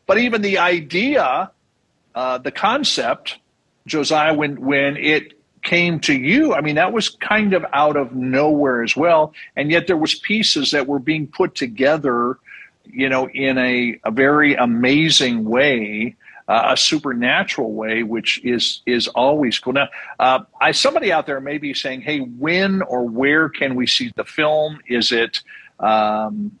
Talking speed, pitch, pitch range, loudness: 165 wpm, 140 Hz, 125-160 Hz, -17 LUFS